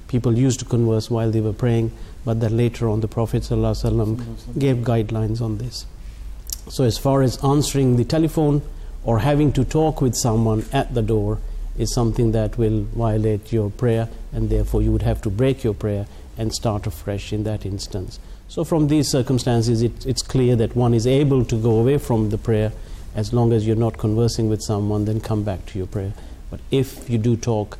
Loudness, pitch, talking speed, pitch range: -21 LUFS, 115 Hz, 200 wpm, 110-125 Hz